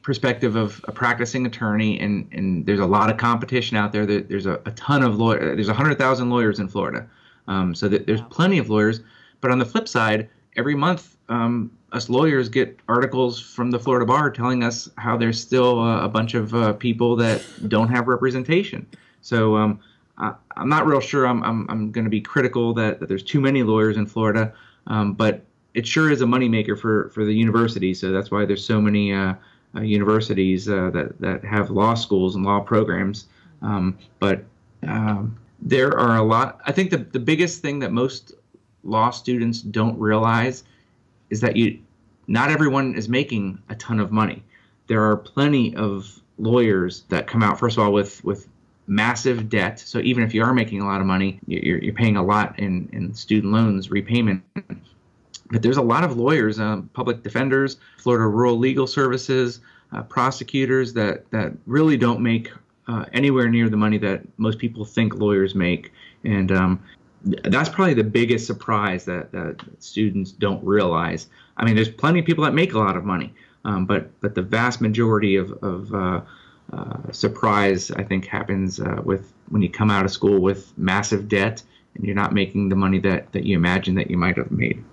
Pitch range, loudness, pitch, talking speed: 100-120 Hz, -21 LUFS, 110 Hz, 195 wpm